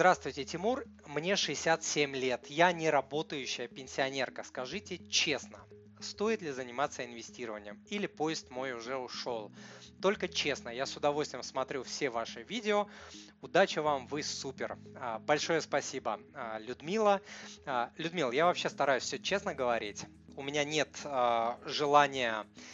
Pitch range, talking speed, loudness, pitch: 120-170 Hz, 125 wpm, -33 LUFS, 145 Hz